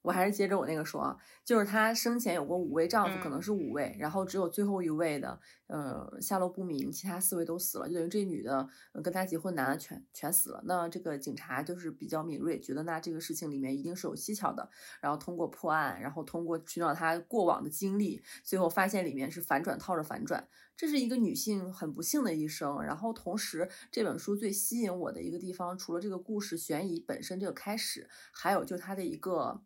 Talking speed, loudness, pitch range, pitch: 345 characters per minute, -34 LUFS, 160-200 Hz, 180 Hz